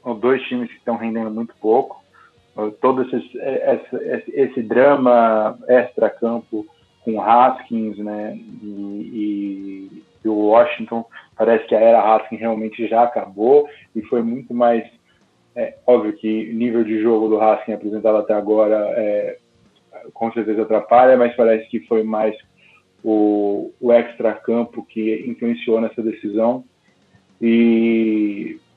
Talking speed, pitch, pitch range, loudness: 125 wpm, 115 Hz, 110-120 Hz, -18 LUFS